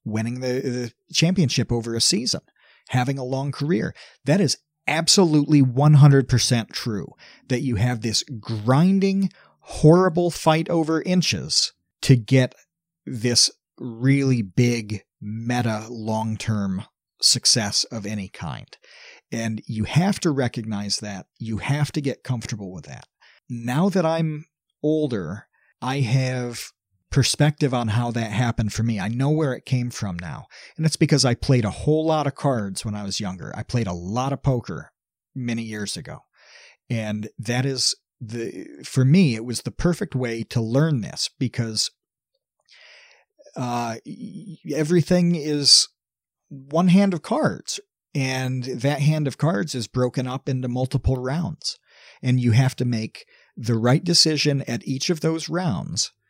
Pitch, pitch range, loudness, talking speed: 130 Hz, 115-155 Hz, -22 LUFS, 145 wpm